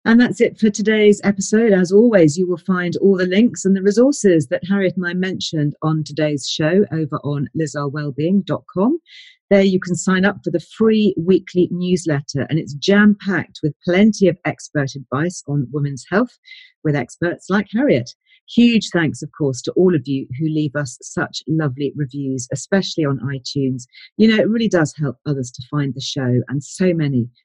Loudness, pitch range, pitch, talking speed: -18 LUFS, 145-200 Hz, 170 Hz, 185 wpm